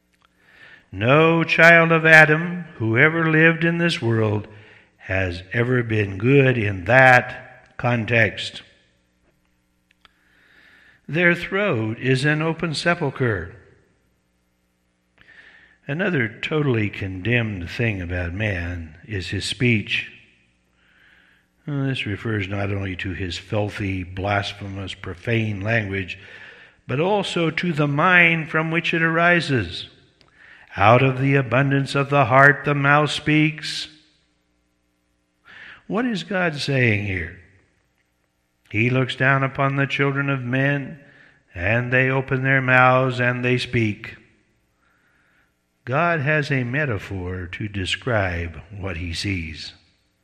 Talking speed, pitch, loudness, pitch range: 110 wpm, 115 Hz, -19 LUFS, 95-140 Hz